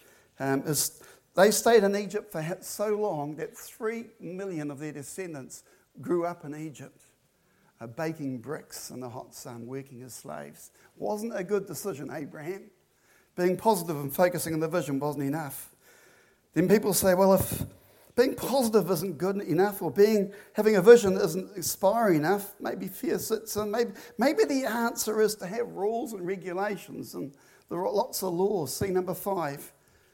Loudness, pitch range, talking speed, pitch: -27 LUFS, 155-210 Hz, 165 wpm, 185 Hz